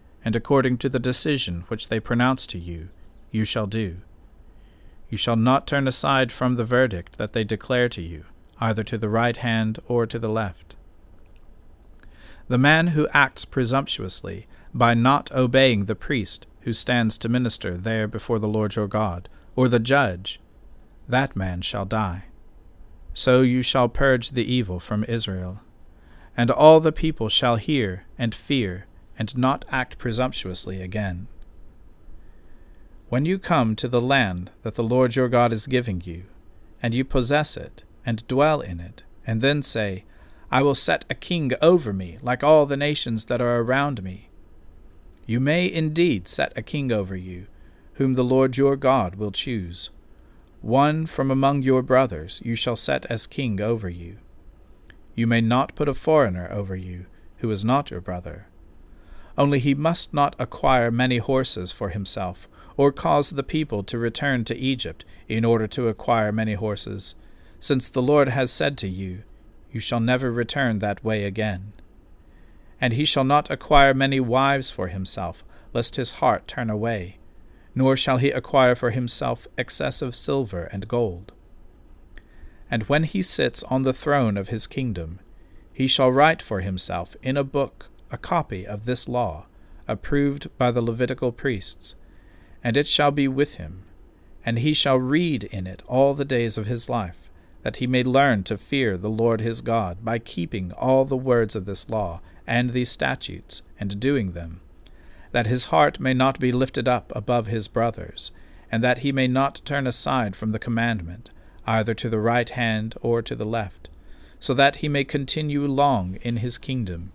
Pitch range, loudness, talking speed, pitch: 90-130 Hz, -23 LUFS, 170 wpm, 115 Hz